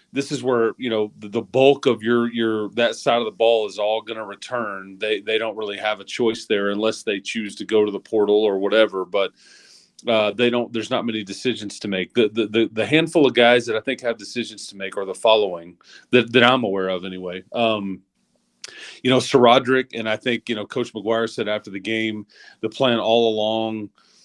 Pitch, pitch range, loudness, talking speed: 110 Hz, 105-120 Hz, -21 LUFS, 225 wpm